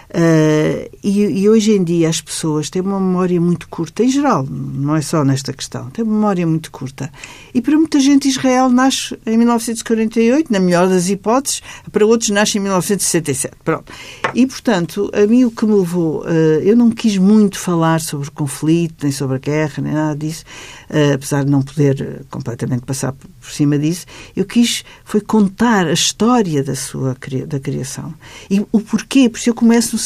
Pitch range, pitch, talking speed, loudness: 145-220 Hz, 175 Hz, 190 wpm, -15 LUFS